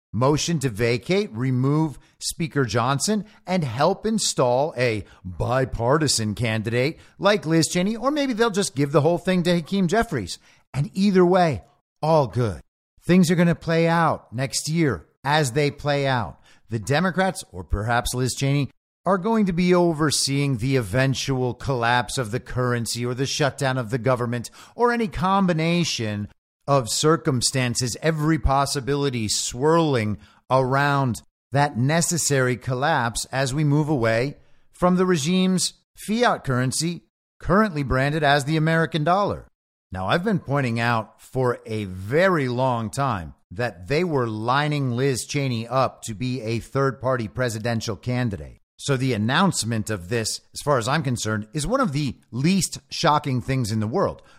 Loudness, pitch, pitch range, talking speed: -22 LUFS, 135 Hz, 120-160 Hz, 150 wpm